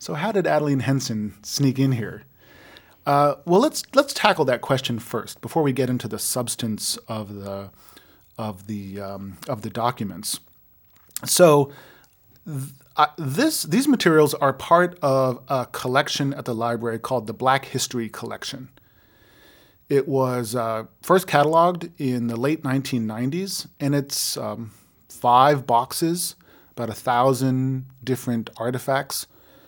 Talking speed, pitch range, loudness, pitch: 135 wpm, 115-145 Hz, -22 LUFS, 130 Hz